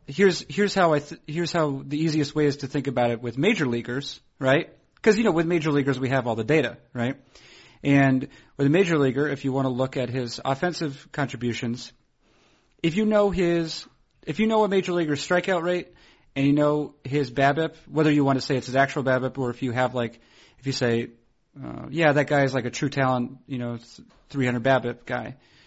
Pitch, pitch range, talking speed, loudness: 140 Hz, 130-160 Hz, 215 wpm, -24 LUFS